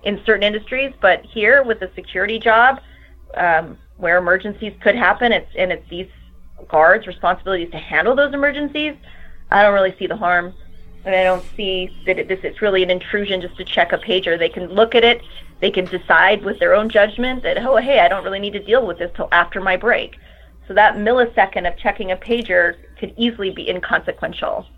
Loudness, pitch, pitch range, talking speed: -17 LUFS, 195 Hz, 180-220 Hz, 205 wpm